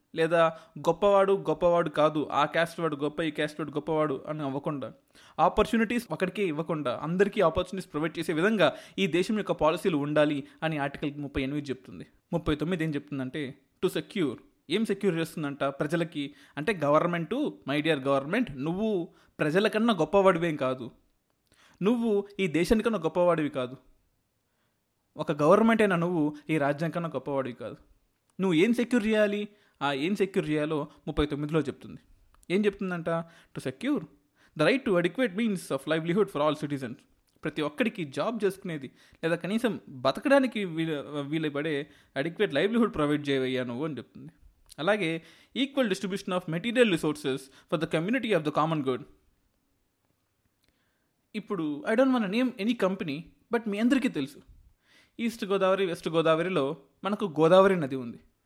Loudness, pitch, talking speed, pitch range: -28 LUFS, 165 Hz, 140 wpm, 145-200 Hz